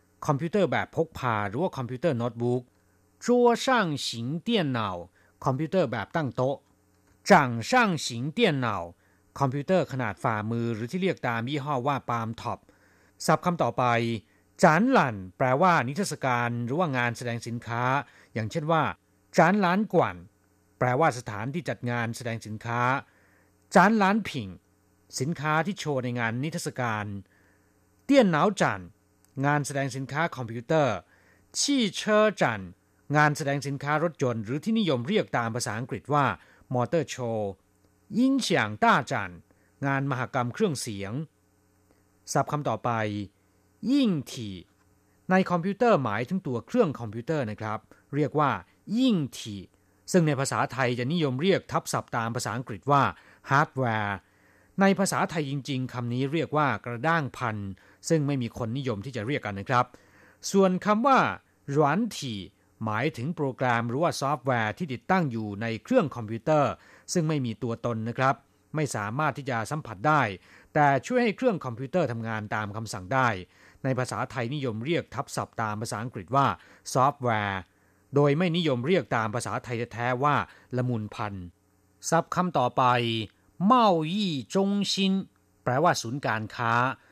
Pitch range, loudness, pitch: 105-155 Hz, -27 LUFS, 125 Hz